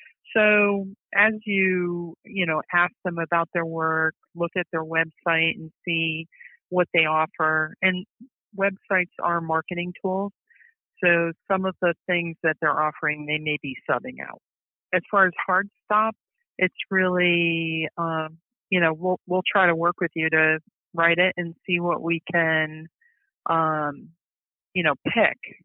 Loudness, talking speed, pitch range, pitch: -23 LUFS, 155 wpm, 160-190 Hz, 175 Hz